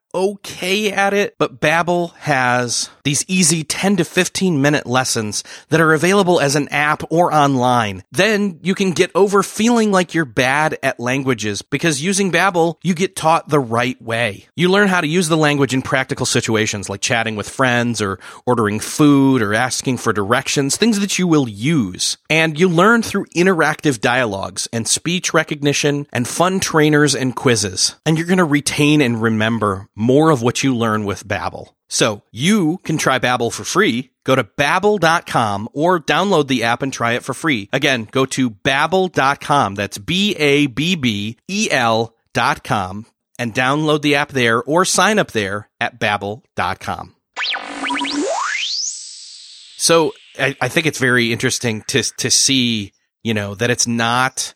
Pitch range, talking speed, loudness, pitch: 120-170 Hz, 165 wpm, -16 LUFS, 140 Hz